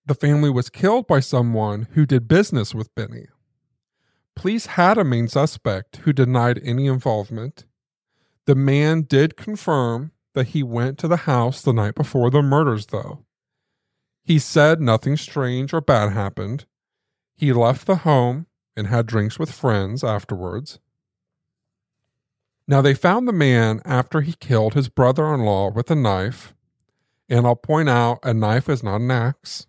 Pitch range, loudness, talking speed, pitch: 115-150 Hz, -19 LUFS, 160 wpm, 130 Hz